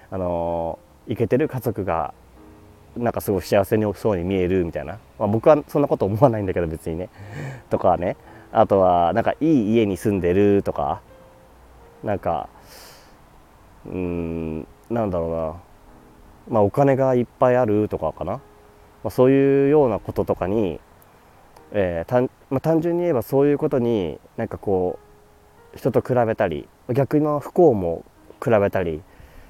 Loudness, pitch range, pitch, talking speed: -21 LUFS, 85-125 Hz, 105 Hz, 295 characters per minute